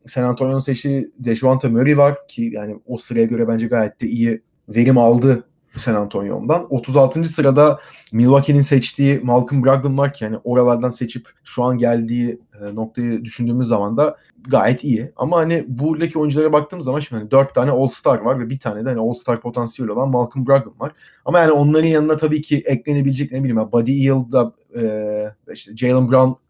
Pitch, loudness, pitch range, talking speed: 130 Hz, -17 LUFS, 120-140 Hz, 175 wpm